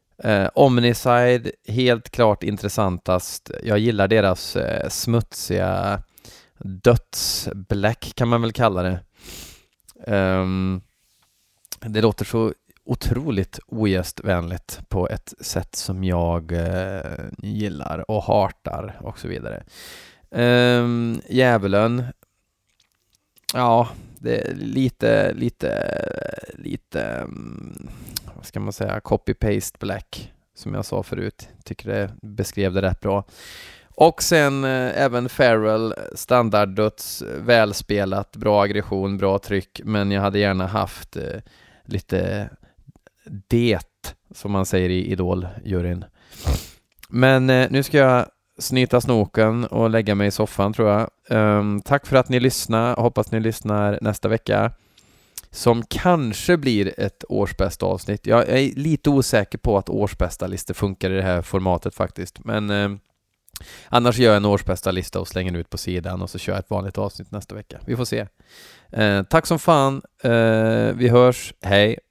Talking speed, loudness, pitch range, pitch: 130 wpm, -21 LUFS, 95-120 Hz, 105 Hz